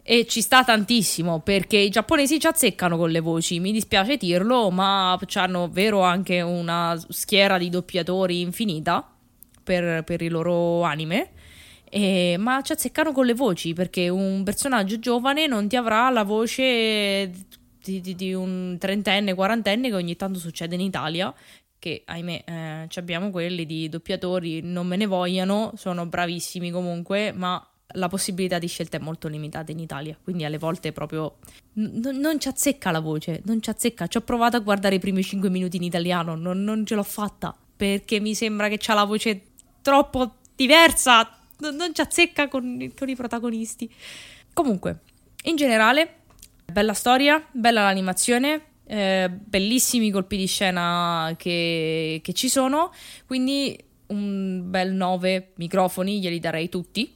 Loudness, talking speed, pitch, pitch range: -23 LUFS, 160 wpm, 195 Hz, 175-230 Hz